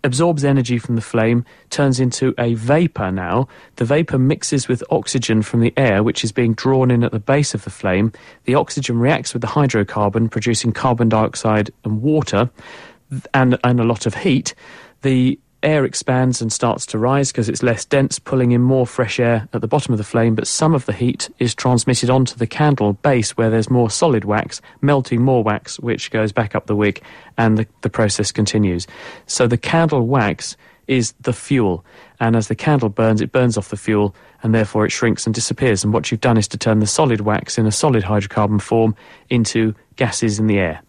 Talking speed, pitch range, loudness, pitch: 205 wpm, 110-130 Hz, -17 LUFS, 115 Hz